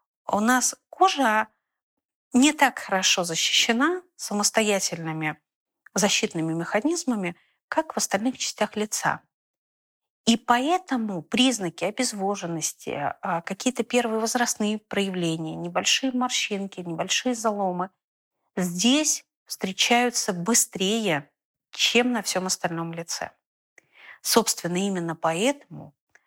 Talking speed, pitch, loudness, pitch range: 85 wpm, 215 Hz, -24 LUFS, 185-250 Hz